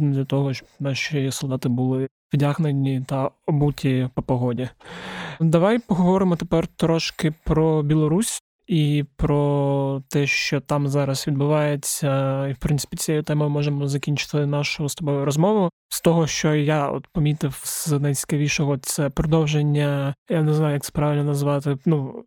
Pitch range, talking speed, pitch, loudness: 140-155 Hz, 145 wpm, 145 Hz, -22 LUFS